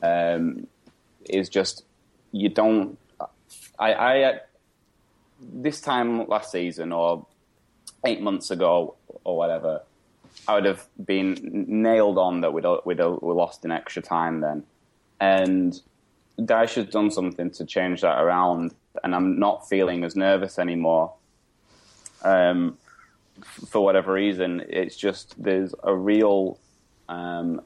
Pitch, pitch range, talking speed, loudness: 95 Hz, 85-100 Hz, 125 wpm, -24 LUFS